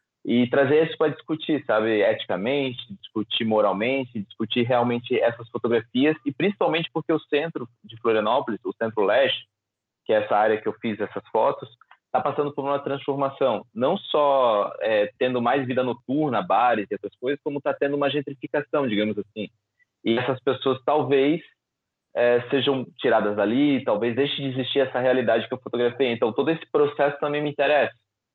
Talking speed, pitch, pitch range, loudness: 165 wpm, 130 Hz, 115-145 Hz, -24 LUFS